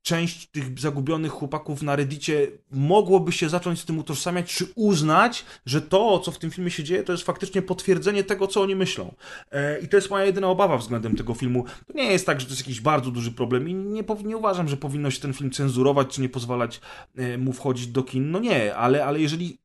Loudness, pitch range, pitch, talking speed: -24 LUFS, 135-185 Hz, 155 Hz, 220 wpm